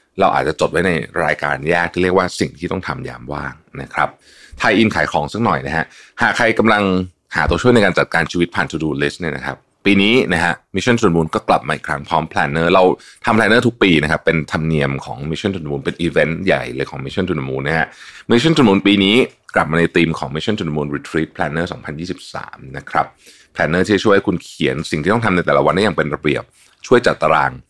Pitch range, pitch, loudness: 75-95 Hz, 85 Hz, -16 LUFS